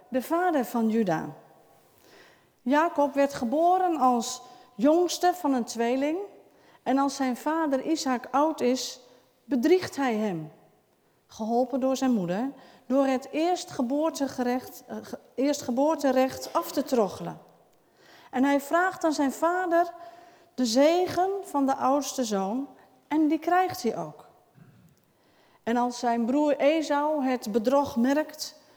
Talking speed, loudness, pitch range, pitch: 125 wpm, -26 LUFS, 250-320 Hz, 275 Hz